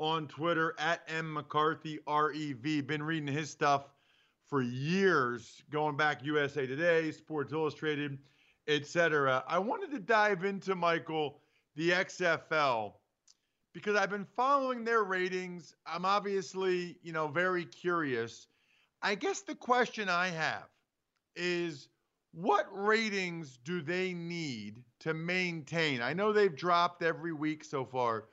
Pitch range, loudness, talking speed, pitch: 150-185 Hz, -33 LUFS, 130 wpm, 165 Hz